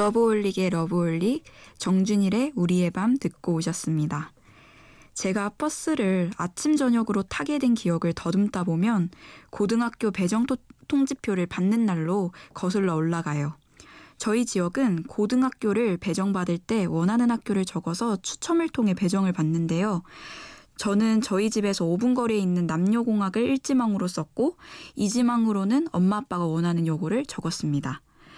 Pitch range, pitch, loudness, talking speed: 175-230 Hz, 200 Hz, -25 LUFS, 315 characters per minute